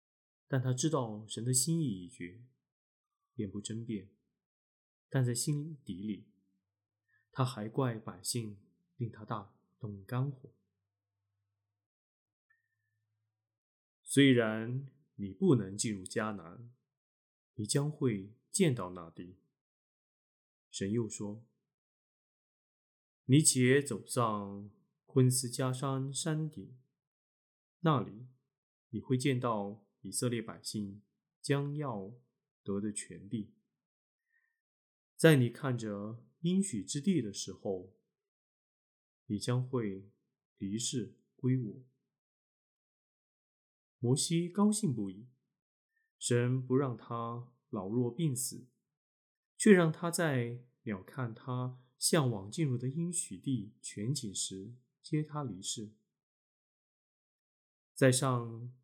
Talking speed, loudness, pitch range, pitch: 135 characters per minute, -34 LUFS, 105-140 Hz, 120 Hz